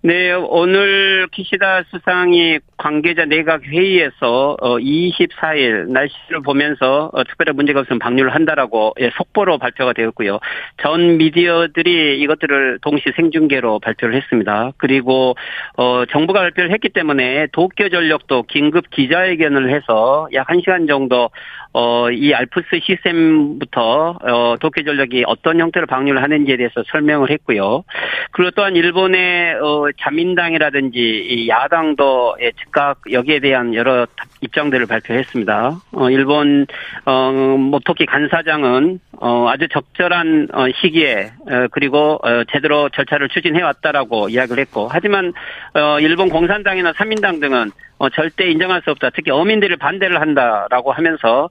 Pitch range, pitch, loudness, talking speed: 135-175 Hz, 150 Hz, -15 LUFS, 315 characters per minute